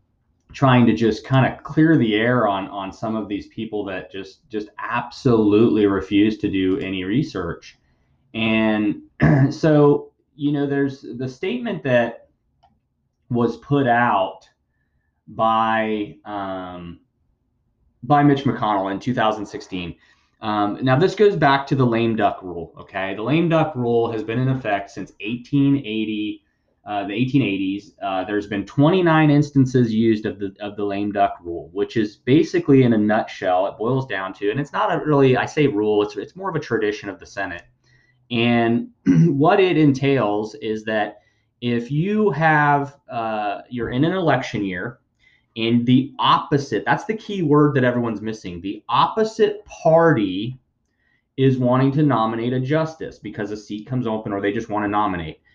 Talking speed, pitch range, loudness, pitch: 160 wpm, 105-140 Hz, -20 LUFS, 120 Hz